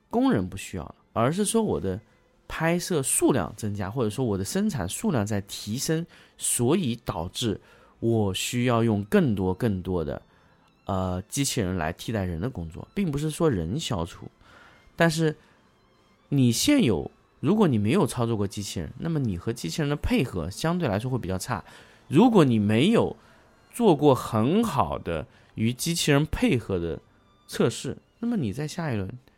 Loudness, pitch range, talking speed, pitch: -26 LUFS, 100-155 Hz, 245 characters per minute, 115 Hz